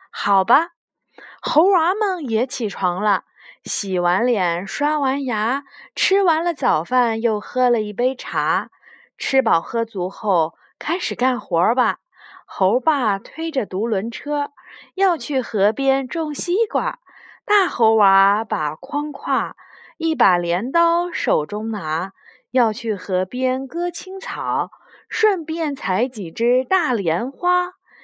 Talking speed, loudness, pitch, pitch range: 165 characters per minute, -20 LUFS, 255 Hz, 210-325 Hz